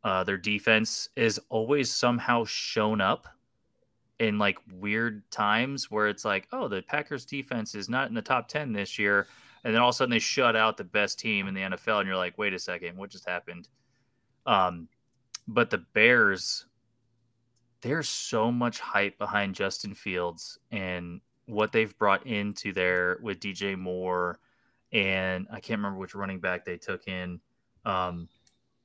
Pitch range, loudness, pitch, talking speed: 95-120 Hz, -28 LUFS, 105 Hz, 170 wpm